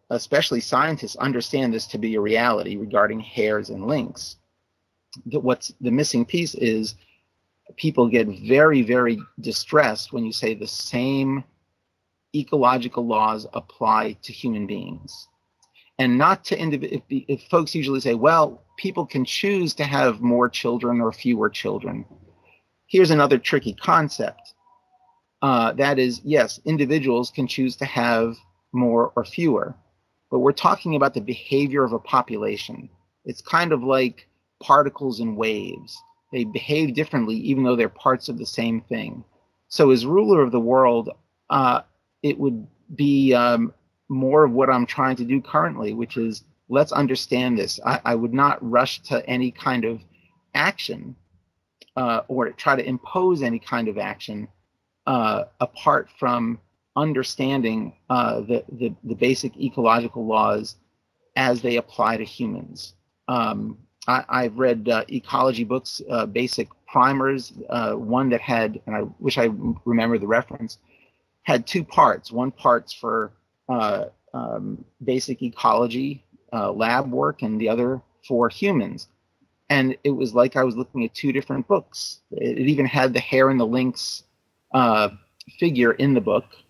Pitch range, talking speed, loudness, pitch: 115-140 Hz, 150 wpm, -22 LUFS, 125 Hz